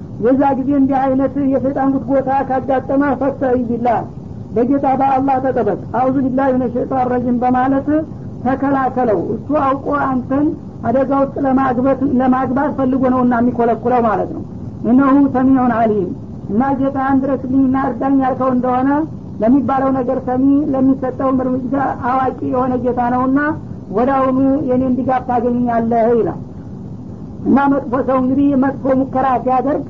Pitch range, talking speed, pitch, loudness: 250-270 Hz, 125 wpm, 265 Hz, -15 LUFS